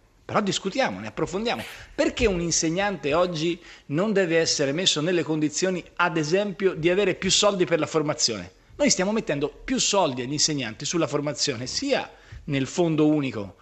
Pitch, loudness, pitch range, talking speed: 165 Hz, -24 LUFS, 150-190 Hz, 160 wpm